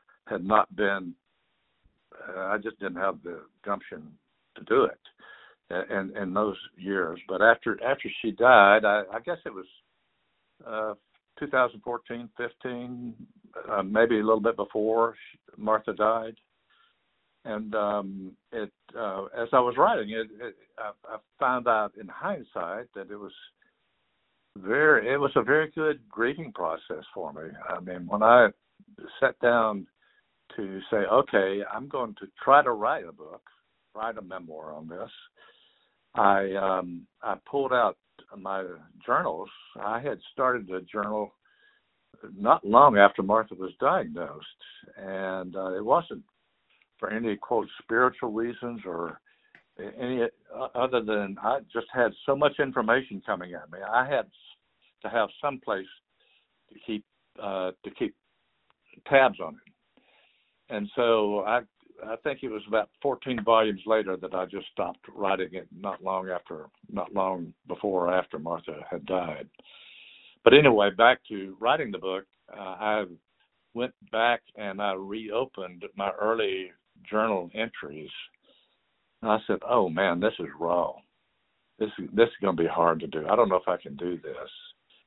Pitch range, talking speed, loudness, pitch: 95-120 Hz, 150 wpm, -26 LUFS, 105 Hz